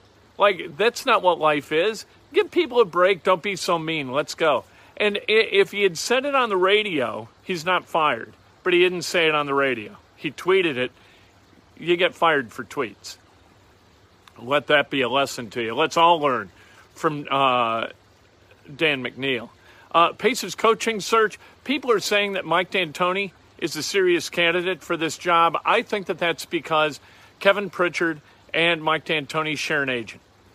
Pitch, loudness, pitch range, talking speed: 165 Hz, -22 LUFS, 125-195 Hz, 175 wpm